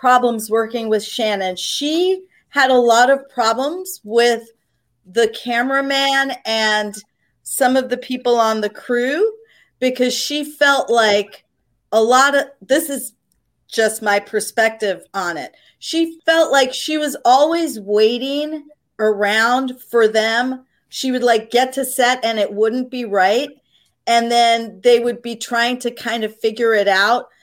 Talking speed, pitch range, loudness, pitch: 150 wpm, 220-270 Hz, -17 LUFS, 240 Hz